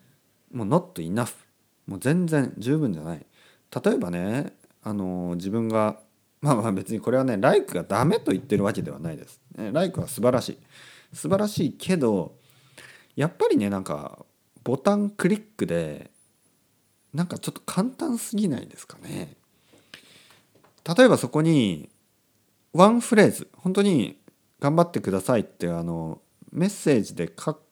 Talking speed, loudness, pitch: 305 characters per minute, -24 LUFS, 150 Hz